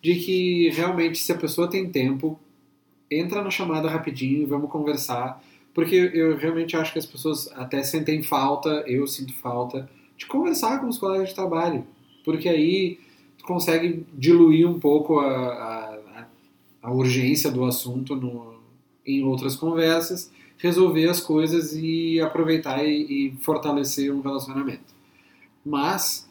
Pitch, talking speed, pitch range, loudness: 155 Hz, 140 wpm, 135-165 Hz, -23 LUFS